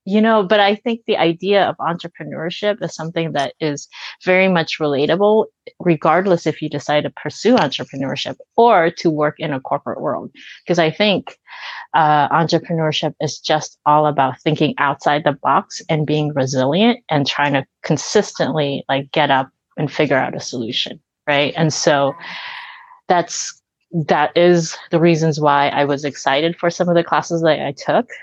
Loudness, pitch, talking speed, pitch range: -17 LUFS, 160 Hz, 165 wpm, 145-185 Hz